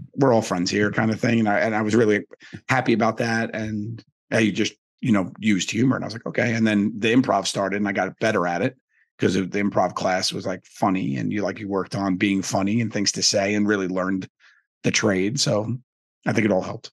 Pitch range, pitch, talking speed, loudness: 100-115 Hz, 105 Hz, 250 wpm, -22 LUFS